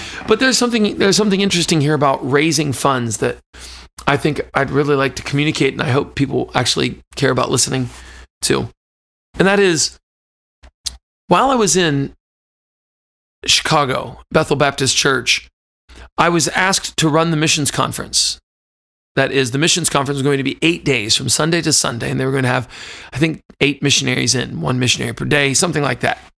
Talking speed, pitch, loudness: 180 wpm, 140 Hz, -16 LUFS